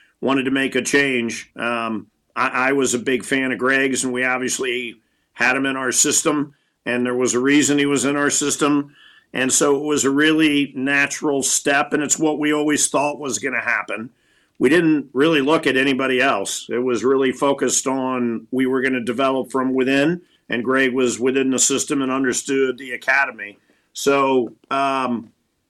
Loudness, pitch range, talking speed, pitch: -19 LUFS, 125-140 Hz, 190 wpm, 135 Hz